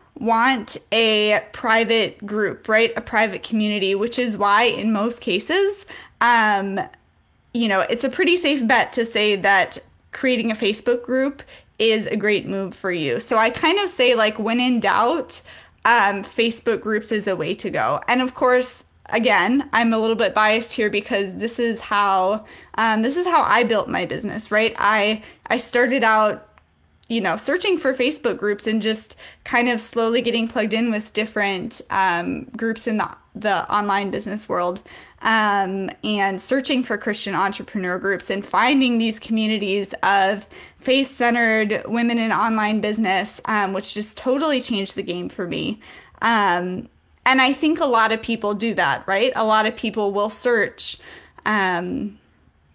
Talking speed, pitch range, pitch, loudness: 165 wpm, 205-240 Hz, 220 Hz, -20 LUFS